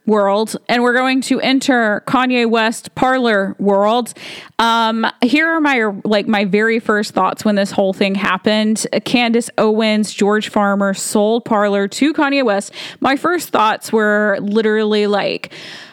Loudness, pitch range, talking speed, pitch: -15 LUFS, 205-240 Hz, 145 wpm, 215 Hz